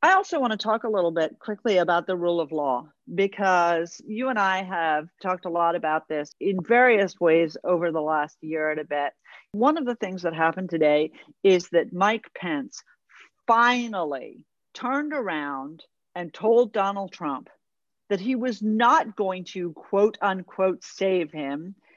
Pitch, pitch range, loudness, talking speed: 185 Hz, 165-220 Hz, -24 LUFS, 170 wpm